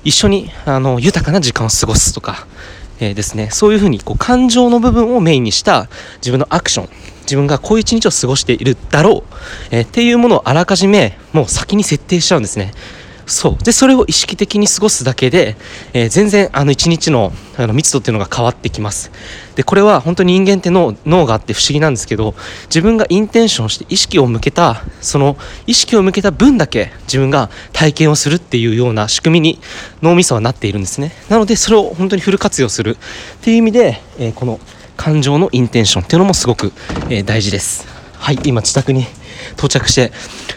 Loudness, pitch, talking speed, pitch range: -12 LUFS, 140 Hz, 420 characters per minute, 110-190 Hz